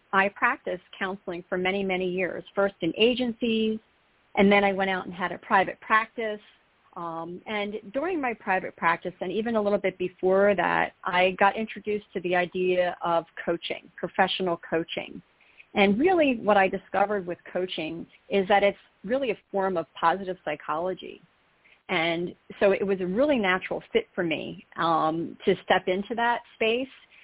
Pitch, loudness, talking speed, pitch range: 195 Hz, -26 LUFS, 165 wpm, 180-215 Hz